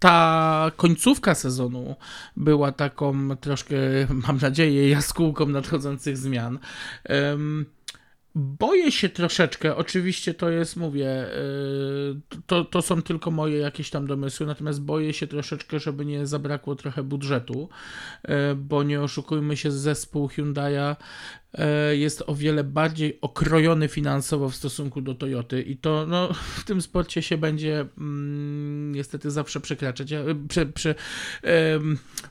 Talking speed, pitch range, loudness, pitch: 130 wpm, 140-155 Hz, -25 LUFS, 150 Hz